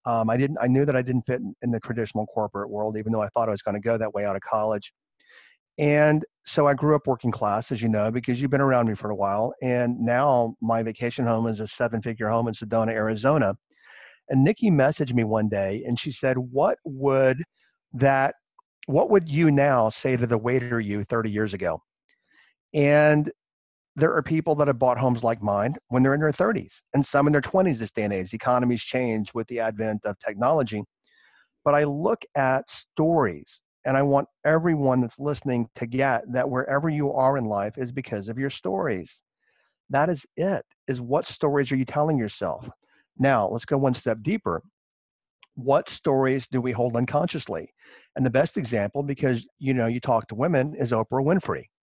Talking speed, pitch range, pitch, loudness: 200 wpm, 115-140 Hz, 125 Hz, -24 LUFS